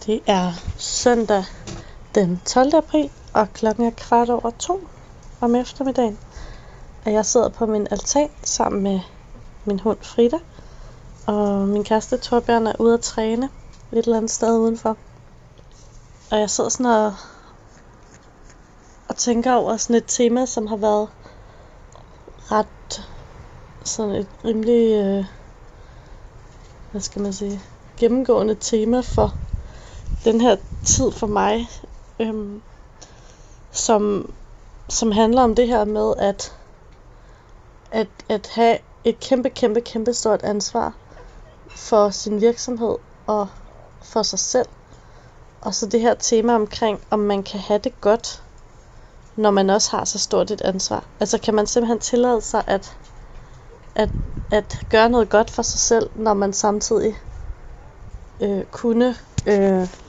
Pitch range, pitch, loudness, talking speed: 205-235 Hz, 220 Hz, -20 LUFS, 135 wpm